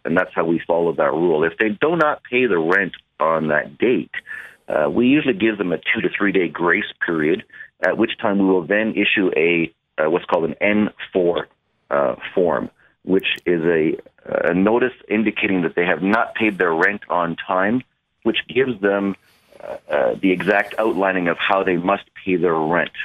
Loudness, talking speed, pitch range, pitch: -19 LUFS, 195 wpm, 90-110 Hz, 100 Hz